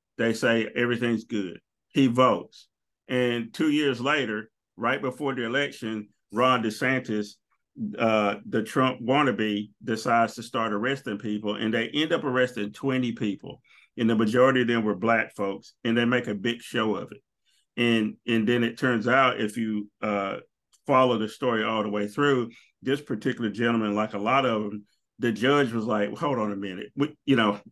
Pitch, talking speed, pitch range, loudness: 115 Hz, 180 wpm, 105-130 Hz, -26 LUFS